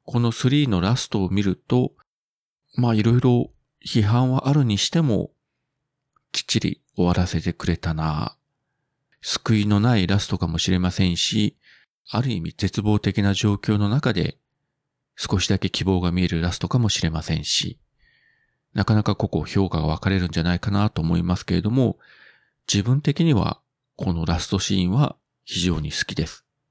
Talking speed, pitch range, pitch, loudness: 310 characters per minute, 90-115 Hz, 100 Hz, -22 LUFS